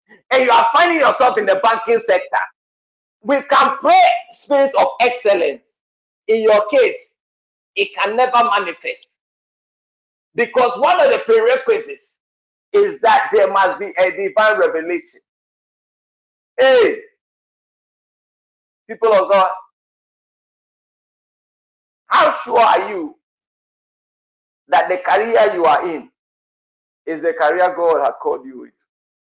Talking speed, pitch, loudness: 115 wpm, 280 Hz, -15 LUFS